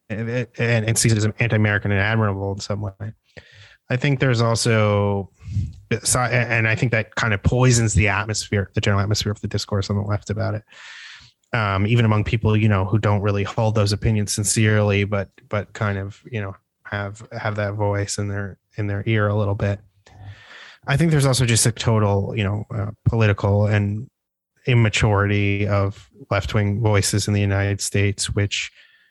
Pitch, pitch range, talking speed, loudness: 105 Hz, 100-115 Hz, 180 wpm, -21 LUFS